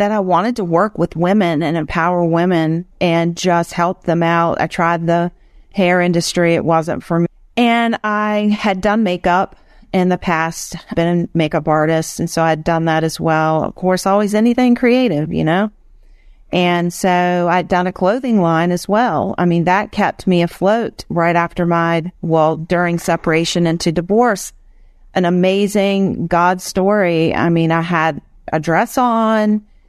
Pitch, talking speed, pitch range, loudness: 175 Hz, 170 wpm, 165-200 Hz, -15 LUFS